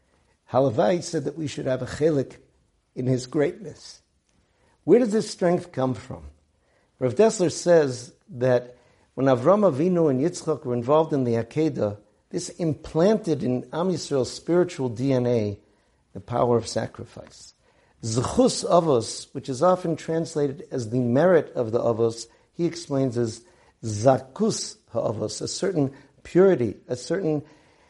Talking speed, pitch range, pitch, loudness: 140 wpm, 120-165 Hz, 135 Hz, -24 LUFS